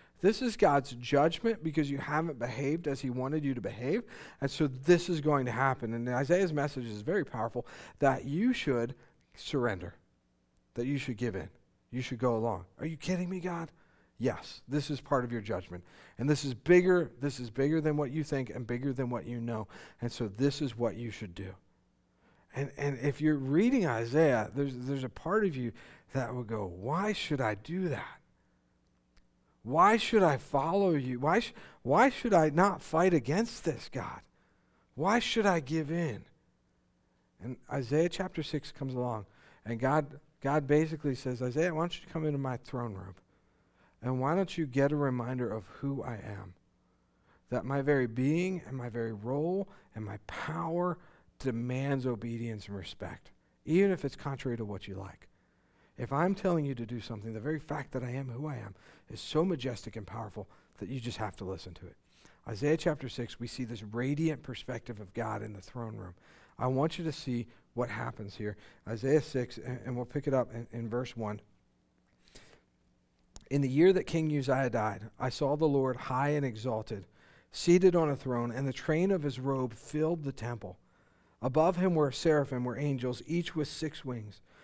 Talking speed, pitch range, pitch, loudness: 190 wpm, 115-155 Hz, 130 Hz, -32 LUFS